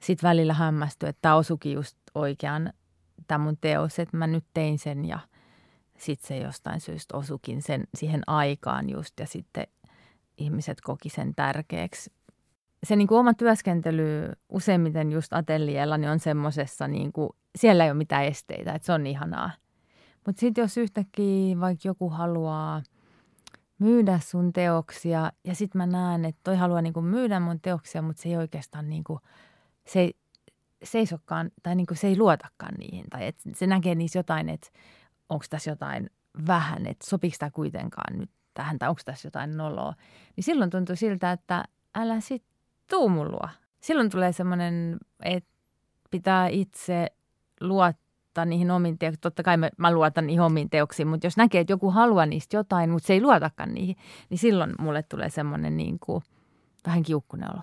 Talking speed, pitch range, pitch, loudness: 160 wpm, 155-185 Hz, 170 Hz, -26 LUFS